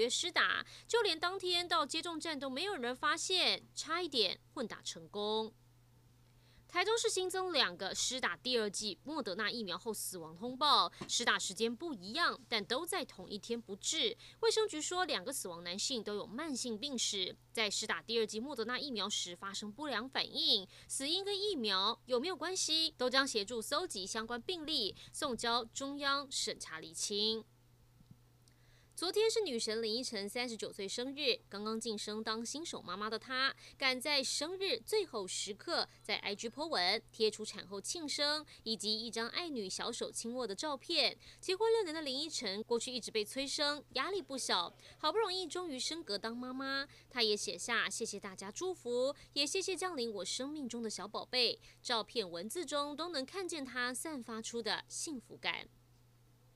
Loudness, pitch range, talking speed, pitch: -36 LUFS, 215-315 Hz, 265 characters per minute, 245 Hz